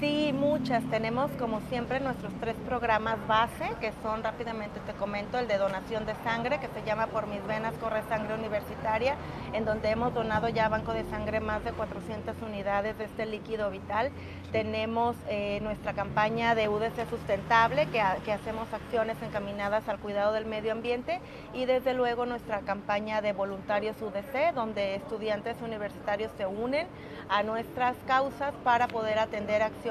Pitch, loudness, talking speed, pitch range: 220 Hz, -31 LUFS, 165 wpm, 210-235 Hz